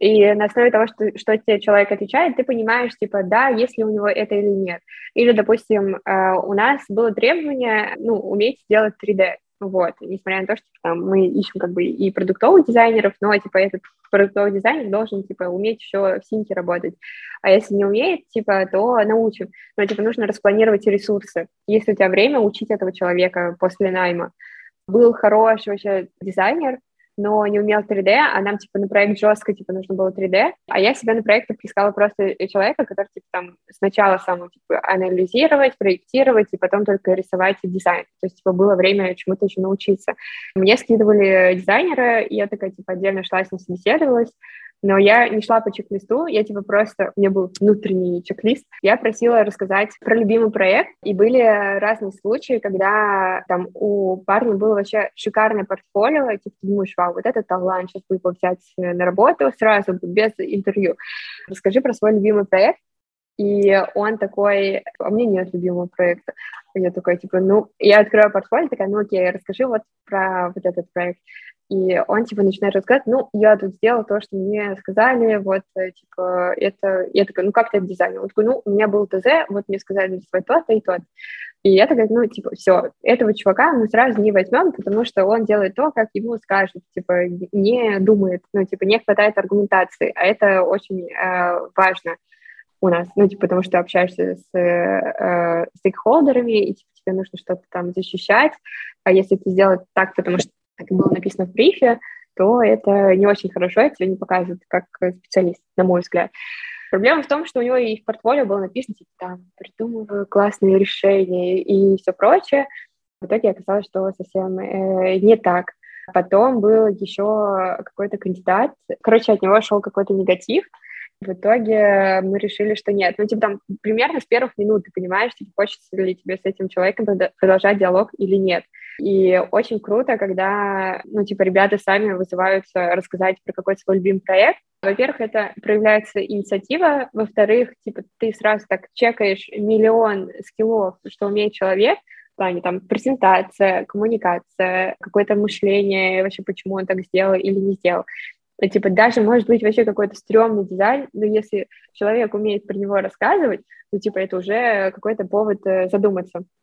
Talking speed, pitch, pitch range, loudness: 175 wpm, 200 Hz, 190-220 Hz, -18 LUFS